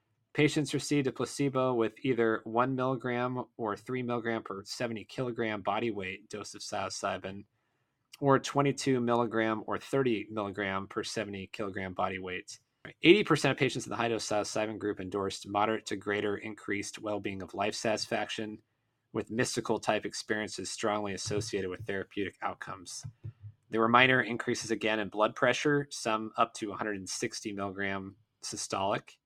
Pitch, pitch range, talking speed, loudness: 110 Hz, 100-125 Hz, 150 wpm, -32 LUFS